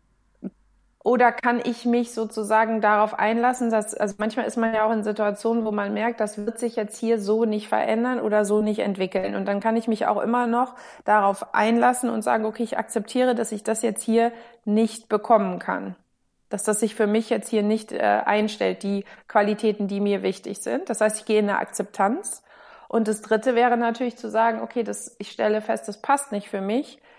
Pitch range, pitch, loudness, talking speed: 210-235 Hz, 220 Hz, -23 LUFS, 205 wpm